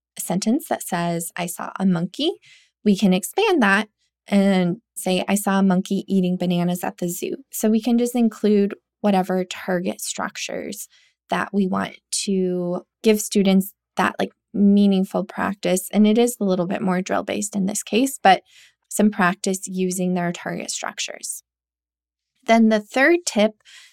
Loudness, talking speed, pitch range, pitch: -21 LUFS, 160 wpm, 180-215 Hz, 195 Hz